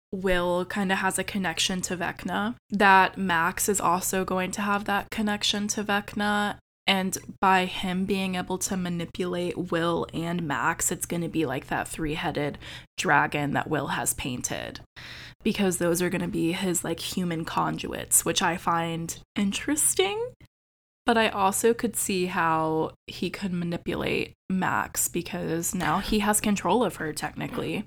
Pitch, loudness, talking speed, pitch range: 185 Hz, -26 LUFS, 160 wpm, 170-200 Hz